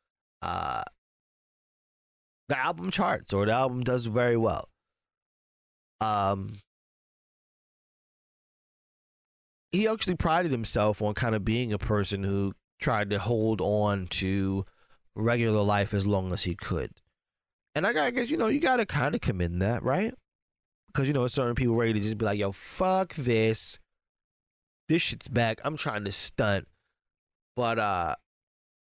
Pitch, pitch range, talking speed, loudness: 110 Hz, 100-125 Hz, 140 wpm, -28 LUFS